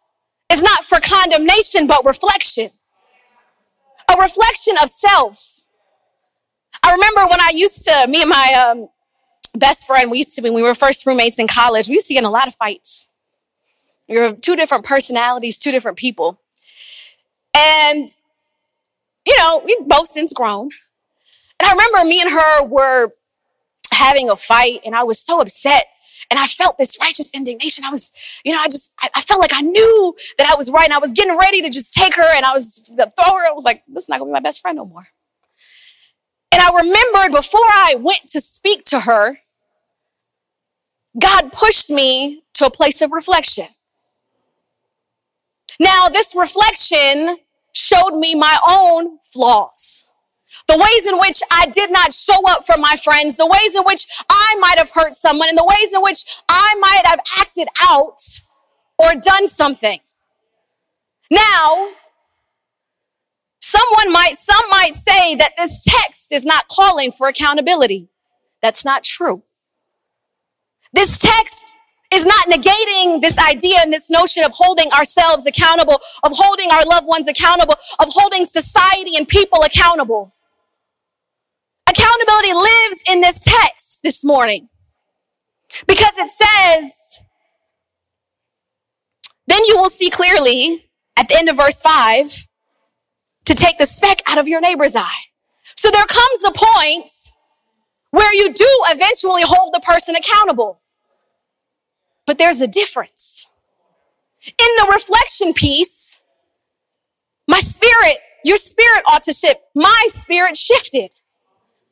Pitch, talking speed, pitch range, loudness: 335 Hz, 150 wpm, 290-390 Hz, -11 LUFS